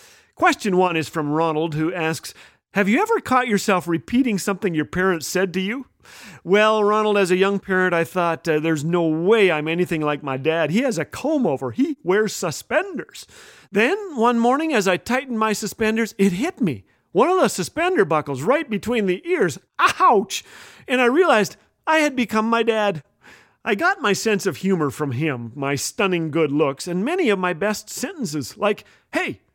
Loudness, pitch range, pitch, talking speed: -20 LUFS, 165-235 Hz, 195 Hz, 190 wpm